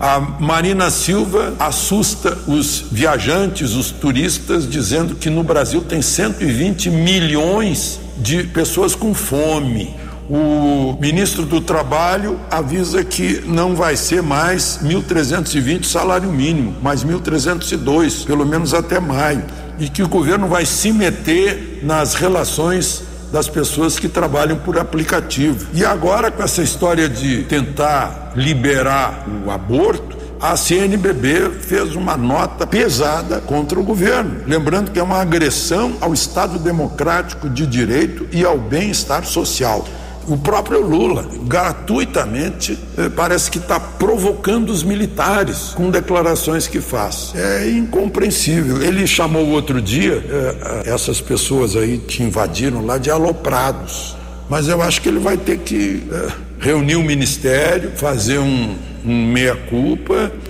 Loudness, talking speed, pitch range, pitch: -16 LUFS, 130 wpm, 140-180 Hz, 160 Hz